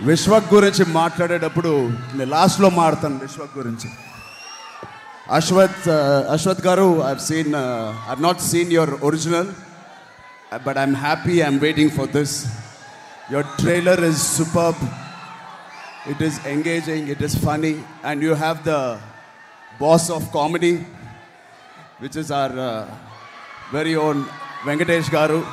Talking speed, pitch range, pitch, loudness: 115 wpm, 140-170 Hz, 155 Hz, -19 LUFS